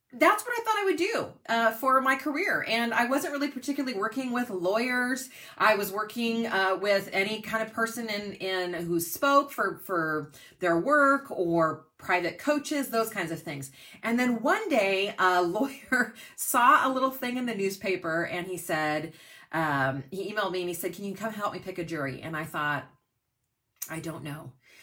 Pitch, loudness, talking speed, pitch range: 200 Hz, -28 LUFS, 195 wpm, 165-250 Hz